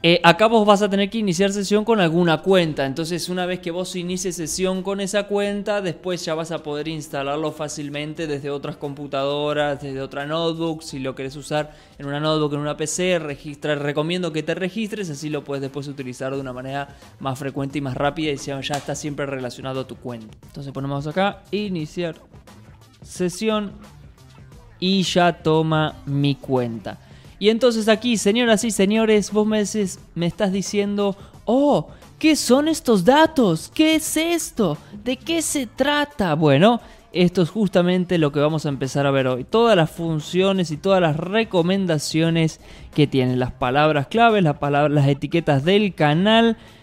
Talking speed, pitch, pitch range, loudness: 175 wpm, 165 Hz, 145-200 Hz, -21 LUFS